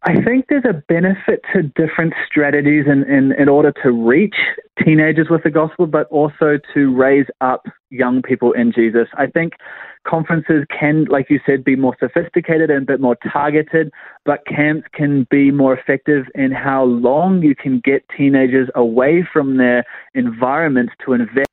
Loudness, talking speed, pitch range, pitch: -15 LUFS, 170 wpm, 135-160 Hz, 145 Hz